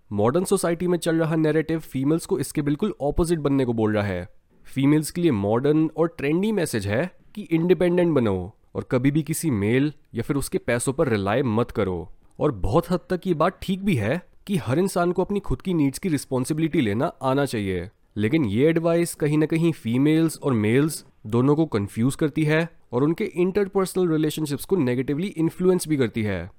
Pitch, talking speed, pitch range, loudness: 155 Hz, 195 wpm, 125-170 Hz, -23 LUFS